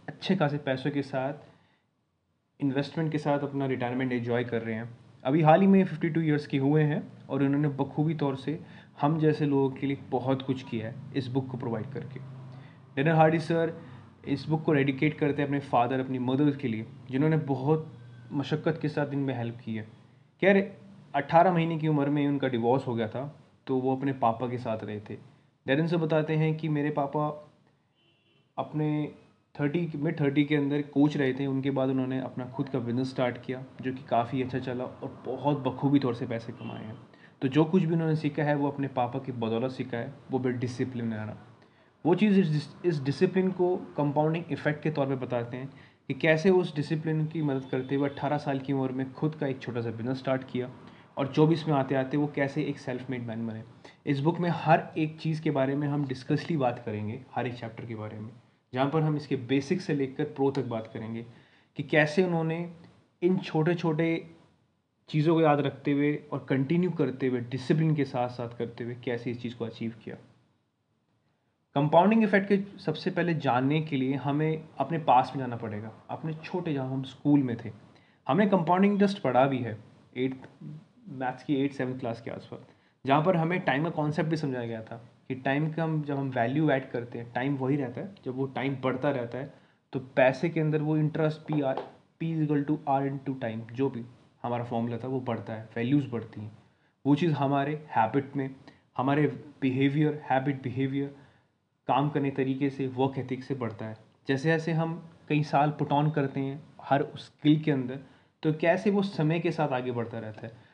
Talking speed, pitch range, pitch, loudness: 205 wpm, 125-155 Hz, 140 Hz, -29 LUFS